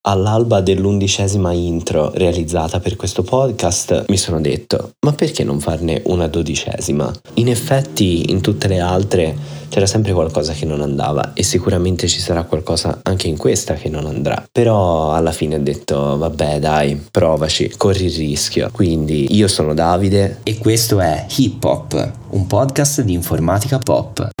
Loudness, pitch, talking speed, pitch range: -16 LUFS, 90 Hz, 155 wpm, 80-105 Hz